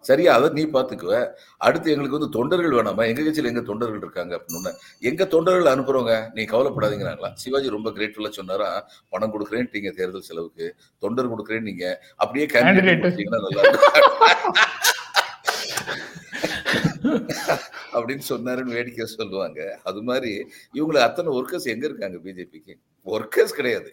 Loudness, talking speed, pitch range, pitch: -21 LUFS, 120 wpm, 110-185 Hz, 130 Hz